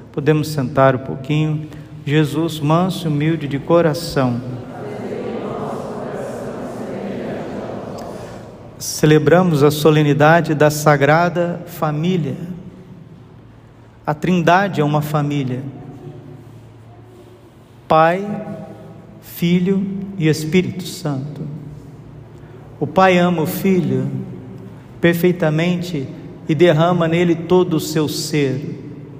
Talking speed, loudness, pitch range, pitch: 80 wpm, -17 LUFS, 135-170 Hz, 155 Hz